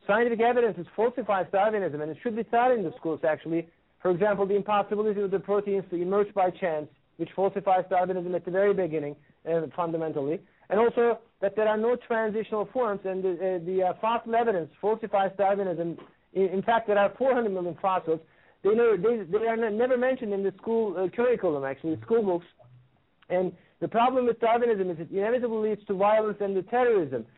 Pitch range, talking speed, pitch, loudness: 180-230 Hz, 195 wpm, 200 Hz, -27 LUFS